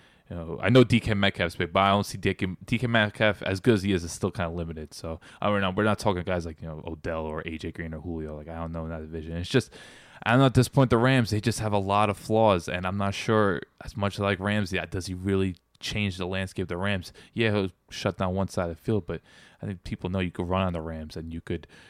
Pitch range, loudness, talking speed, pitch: 85-105 Hz, -27 LUFS, 290 wpm, 95 Hz